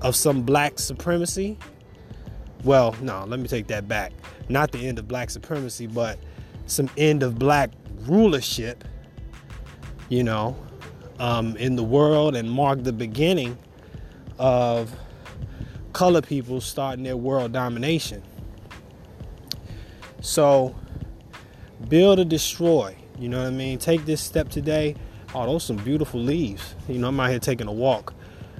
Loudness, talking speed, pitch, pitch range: -23 LUFS, 140 wpm, 130 Hz, 115-145 Hz